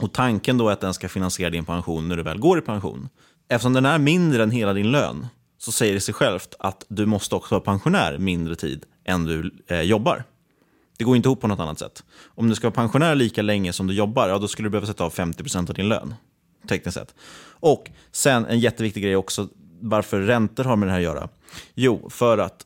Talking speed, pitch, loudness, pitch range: 235 wpm, 105 Hz, -22 LUFS, 90-120 Hz